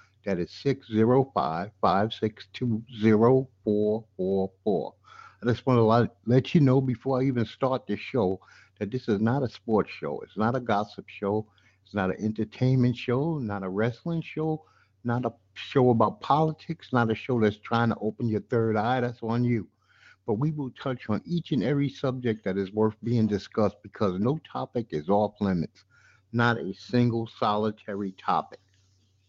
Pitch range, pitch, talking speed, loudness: 105-125 Hz, 115 Hz, 170 wpm, -27 LUFS